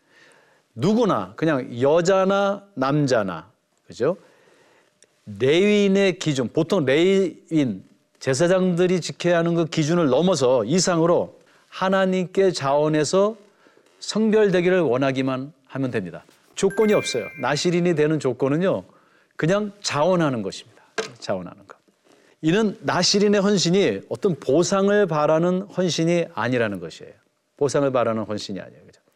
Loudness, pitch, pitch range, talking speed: -21 LUFS, 175 Hz, 150-200 Hz, 285 characters per minute